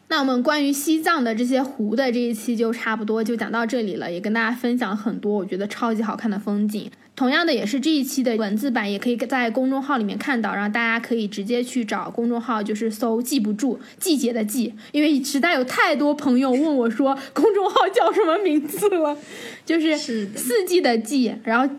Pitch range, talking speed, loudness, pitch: 225-280 Hz, 330 characters per minute, -21 LUFS, 245 Hz